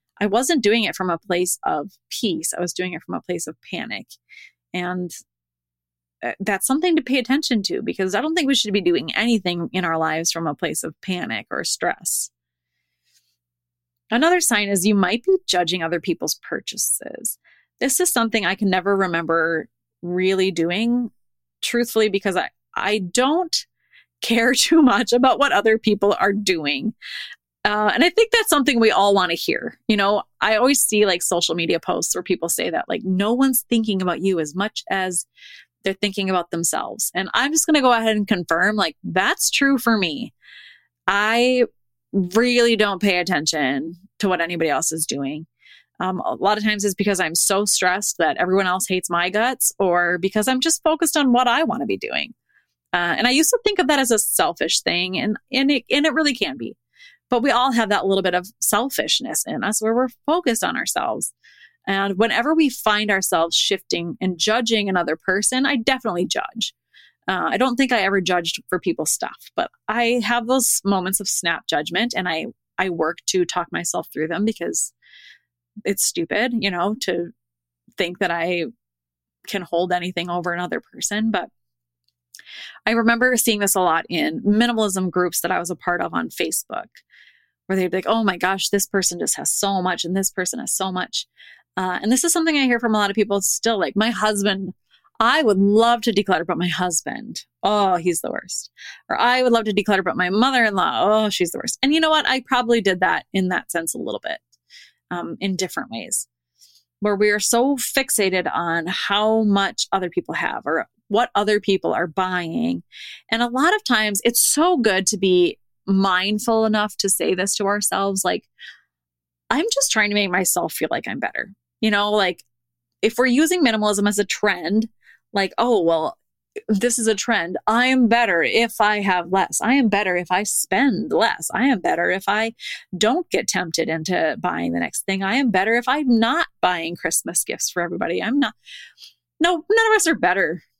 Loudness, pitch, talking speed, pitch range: -20 LUFS, 200 Hz, 195 wpm, 180-235 Hz